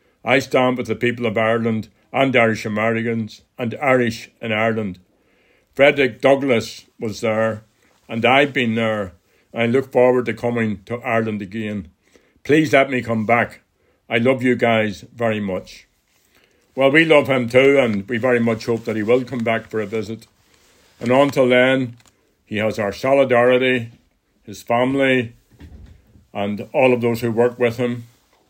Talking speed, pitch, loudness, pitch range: 160 wpm, 115 Hz, -18 LUFS, 110-125 Hz